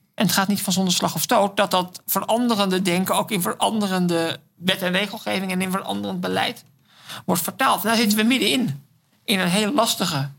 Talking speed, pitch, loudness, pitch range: 200 wpm, 190 Hz, -21 LUFS, 170-205 Hz